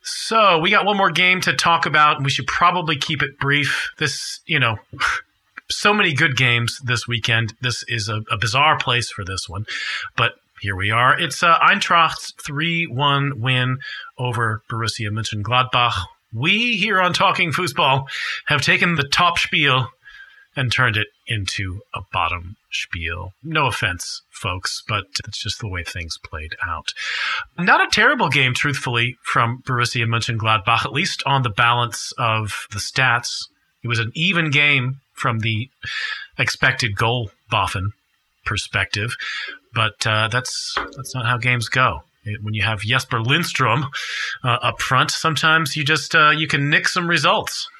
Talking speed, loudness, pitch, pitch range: 160 wpm, -19 LUFS, 130 Hz, 115-155 Hz